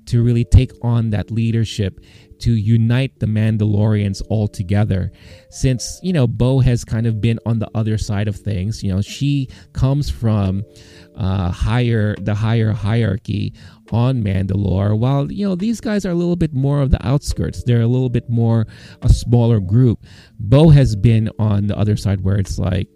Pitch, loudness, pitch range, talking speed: 110 Hz, -18 LUFS, 100-120 Hz, 180 wpm